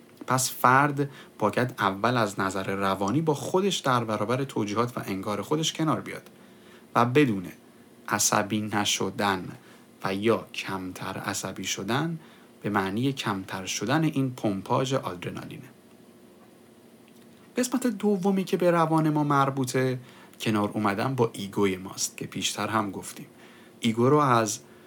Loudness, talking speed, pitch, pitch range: -26 LUFS, 125 wpm, 120 Hz, 100-140 Hz